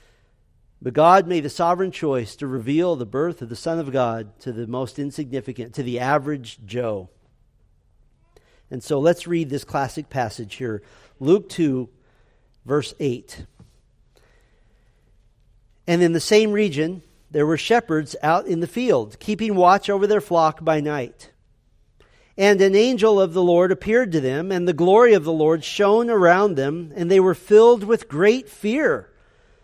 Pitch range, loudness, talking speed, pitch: 125-185 Hz, -20 LUFS, 160 wpm, 155 Hz